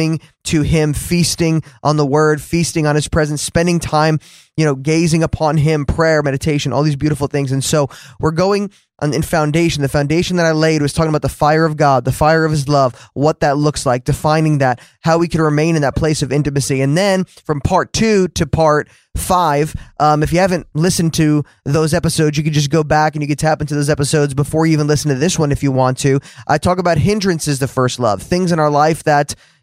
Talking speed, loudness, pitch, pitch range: 230 wpm, -15 LUFS, 155 Hz, 145-160 Hz